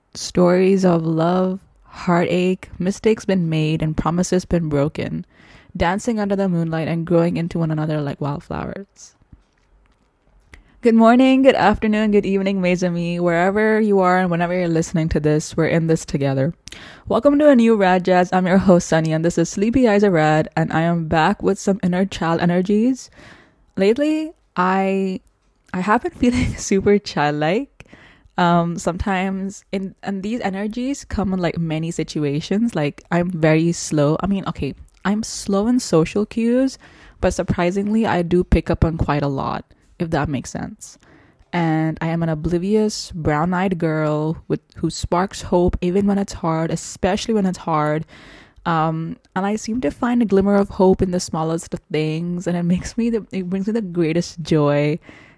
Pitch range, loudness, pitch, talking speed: 160-200 Hz, -19 LUFS, 180 Hz, 170 wpm